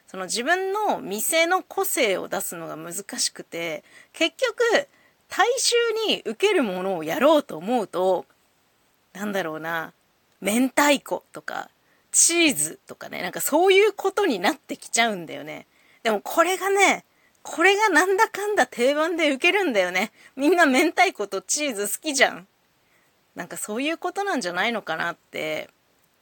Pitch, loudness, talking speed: 300 Hz, -22 LUFS, 305 characters per minute